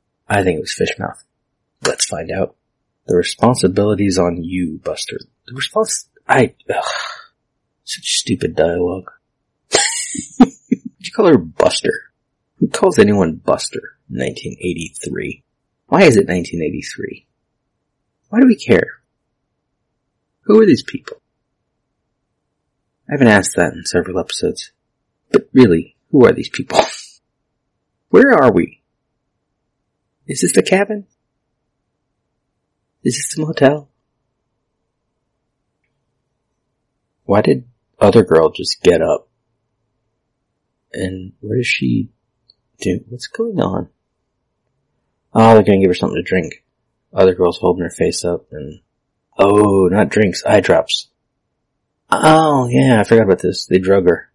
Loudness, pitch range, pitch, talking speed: -15 LUFS, 100-150 Hz, 120 Hz, 125 wpm